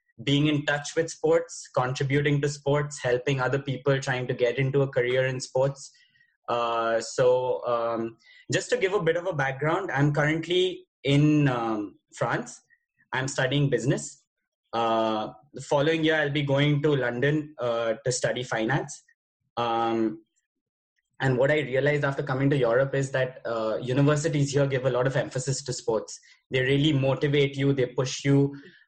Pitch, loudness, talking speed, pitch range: 140 Hz, -26 LUFS, 165 wpm, 130-150 Hz